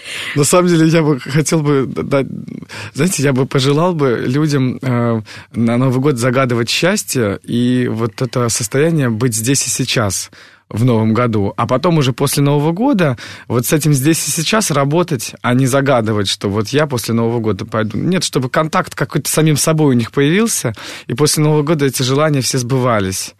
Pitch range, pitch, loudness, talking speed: 120-150 Hz, 135 Hz, -14 LUFS, 175 wpm